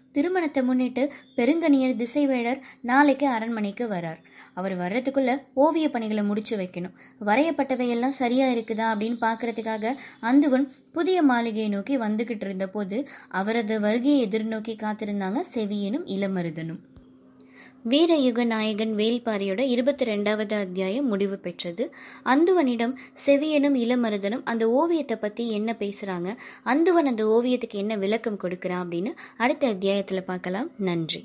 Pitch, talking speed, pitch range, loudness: 230 Hz, 115 wpm, 205-265 Hz, -25 LUFS